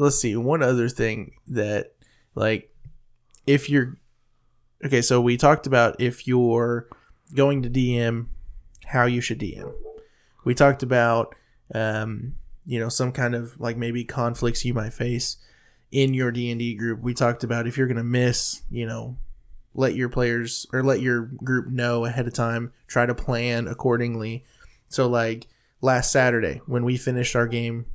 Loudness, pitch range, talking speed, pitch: -23 LUFS, 115-130 Hz, 160 wpm, 120 Hz